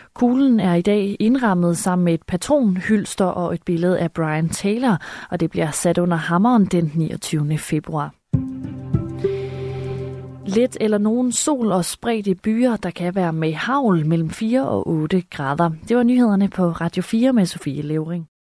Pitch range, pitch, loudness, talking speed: 160-220 Hz, 180 Hz, -20 LUFS, 165 wpm